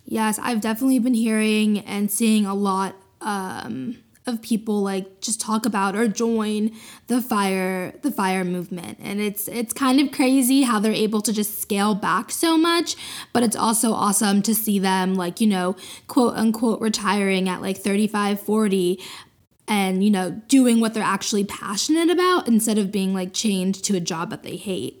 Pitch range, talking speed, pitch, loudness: 195-235 Hz, 180 wpm, 215 Hz, -21 LUFS